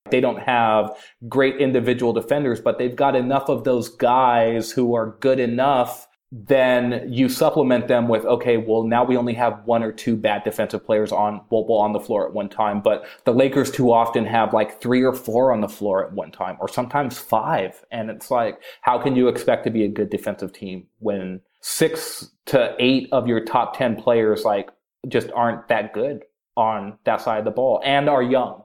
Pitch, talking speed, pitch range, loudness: 120 Hz, 205 wpm, 115-130 Hz, -20 LUFS